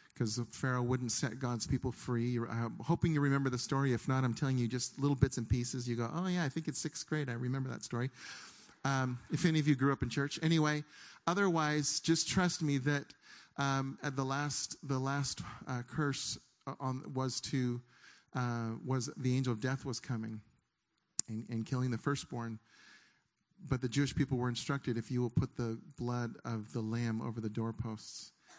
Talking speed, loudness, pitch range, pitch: 195 wpm, -36 LUFS, 120-145 Hz, 130 Hz